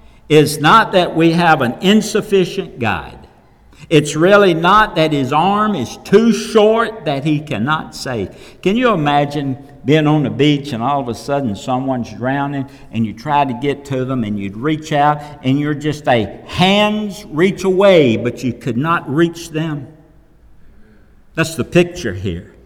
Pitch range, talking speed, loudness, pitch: 130-175 Hz, 165 wpm, -15 LUFS, 150 Hz